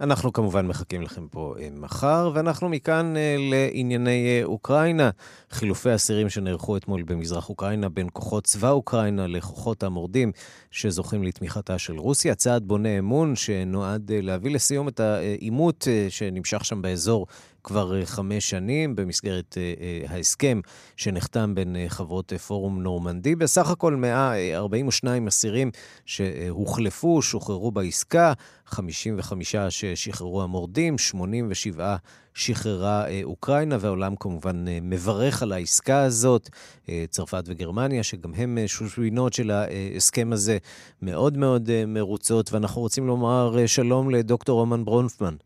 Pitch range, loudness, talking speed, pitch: 95-125 Hz, -24 LUFS, 115 wpm, 105 Hz